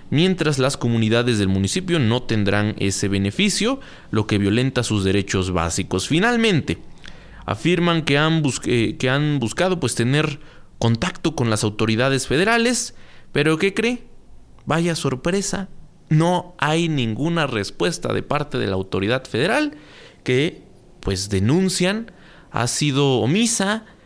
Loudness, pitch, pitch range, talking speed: -20 LUFS, 140 Hz, 110-175 Hz, 125 wpm